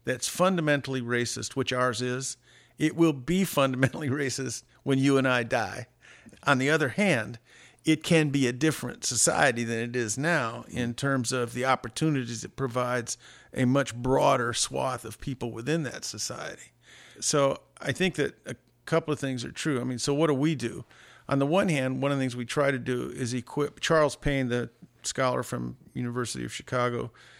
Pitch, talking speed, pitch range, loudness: 135 Hz, 185 wpm, 125-145 Hz, -28 LUFS